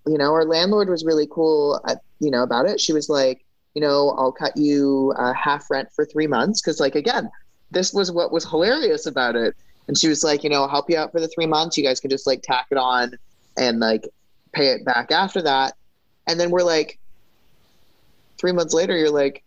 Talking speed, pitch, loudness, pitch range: 230 wpm, 150 Hz, -20 LUFS, 130-165 Hz